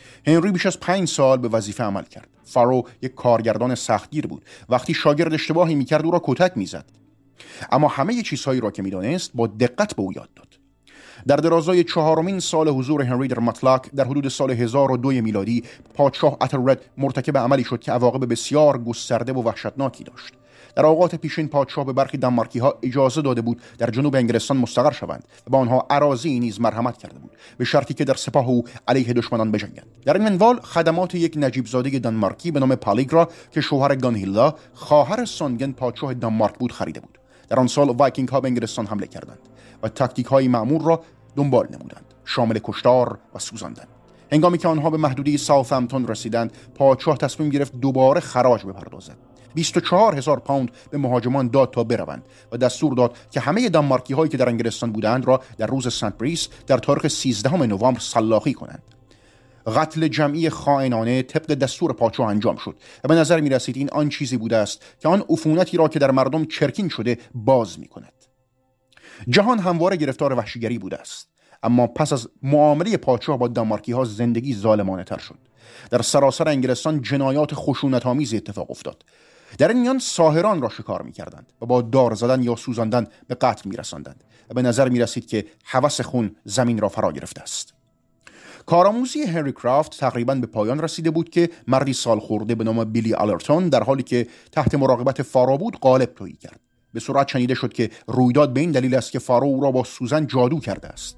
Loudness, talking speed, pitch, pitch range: -20 LUFS, 180 wpm, 130 Hz, 120-150 Hz